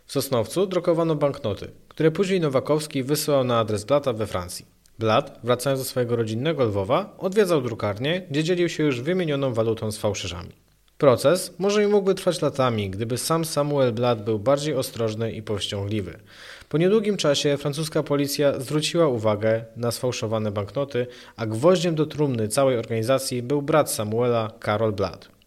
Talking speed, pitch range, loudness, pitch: 155 wpm, 110-155 Hz, -23 LUFS, 130 Hz